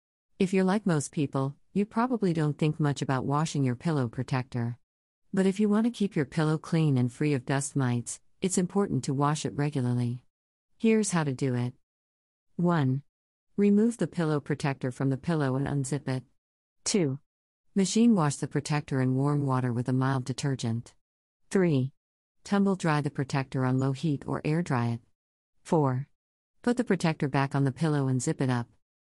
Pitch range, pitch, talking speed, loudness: 130-165 Hz, 140 Hz, 180 wpm, -28 LUFS